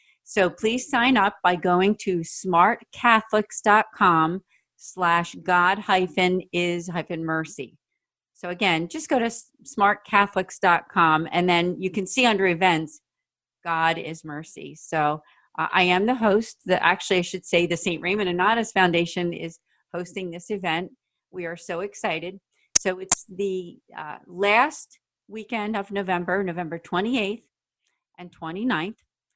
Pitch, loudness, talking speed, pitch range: 185 Hz, -23 LUFS, 135 wpm, 175-205 Hz